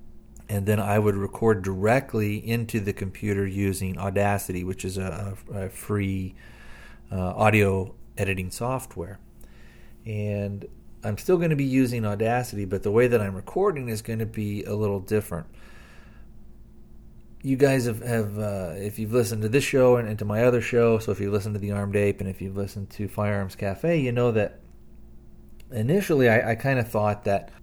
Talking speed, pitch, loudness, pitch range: 180 wpm, 105 Hz, -25 LUFS, 100-115 Hz